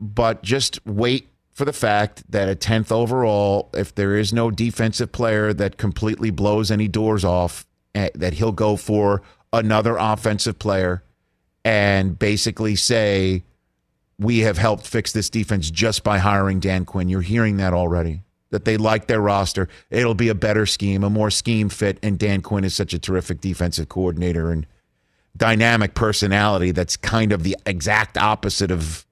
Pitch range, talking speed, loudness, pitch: 95-110 Hz, 165 wpm, -20 LUFS, 105 Hz